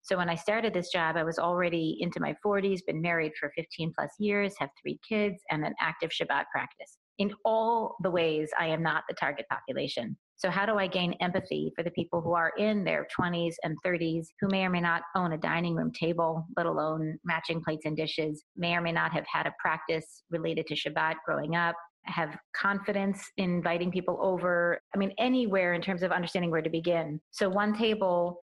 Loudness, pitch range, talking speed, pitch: -30 LUFS, 165-190 Hz, 210 wpm, 175 Hz